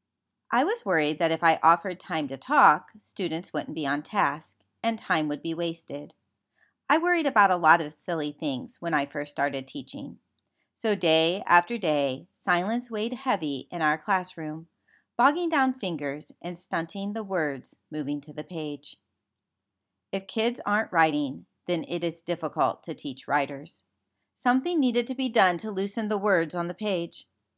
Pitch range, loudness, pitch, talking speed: 150-215 Hz, -26 LUFS, 170 Hz, 170 wpm